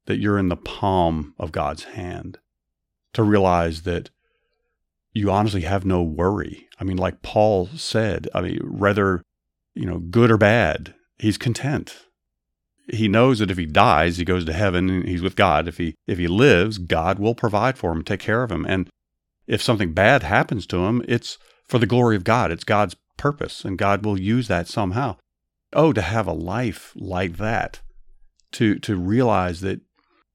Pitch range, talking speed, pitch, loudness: 85-110 Hz, 180 wpm, 95 Hz, -21 LUFS